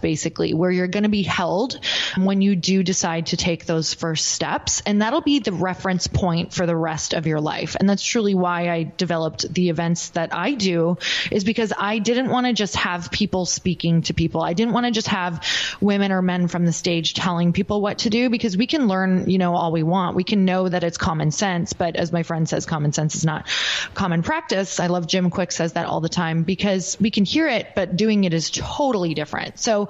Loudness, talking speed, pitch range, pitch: -21 LUFS, 235 wpm, 170-205 Hz, 180 Hz